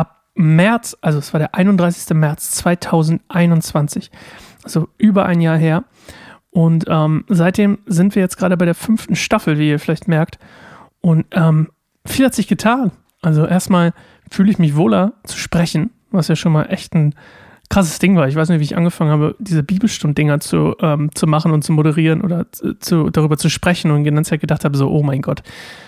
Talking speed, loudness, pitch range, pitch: 185 wpm, -15 LUFS, 155-185 Hz, 165 Hz